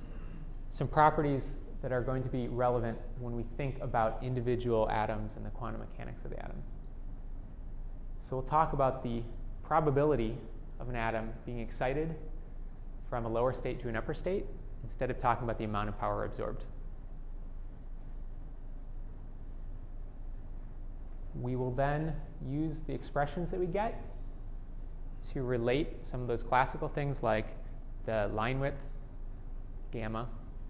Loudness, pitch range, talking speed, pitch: -35 LUFS, 110-135 Hz, 135 wpm, 120 Hz